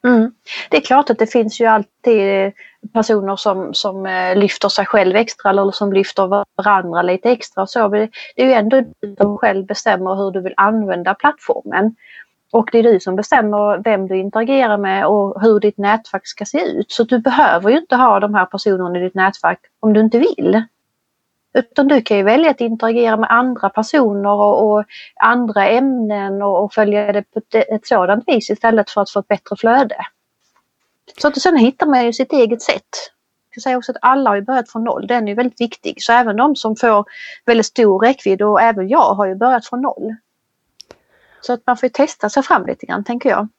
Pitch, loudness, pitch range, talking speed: 220 Hz, -15 LUFS, 200-245 Hz, 200 wpm